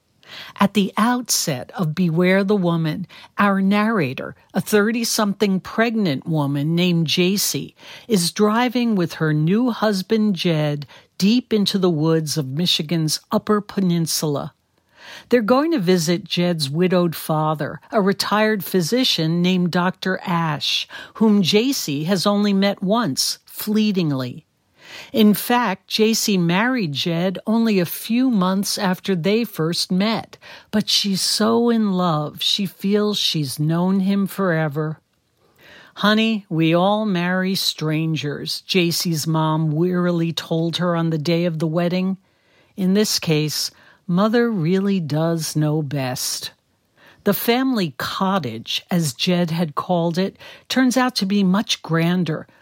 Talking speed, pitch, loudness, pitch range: 130 wpm, 185 Hz, -19 LUFS, 165-210 Hz